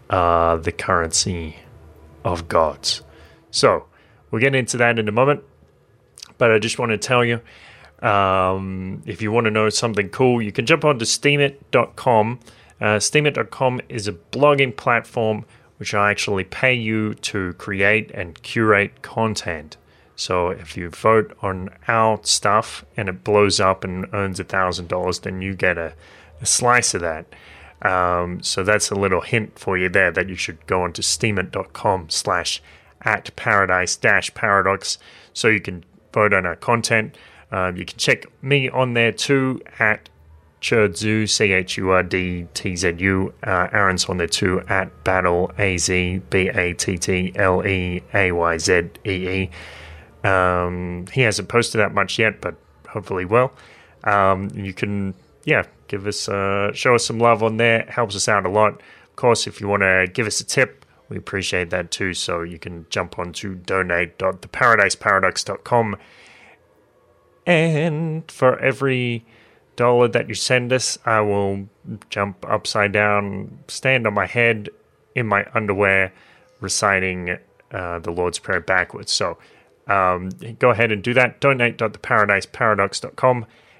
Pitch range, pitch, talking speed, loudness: 90-115 Hz, 100 Hz, 160 wpm, -19 LUFS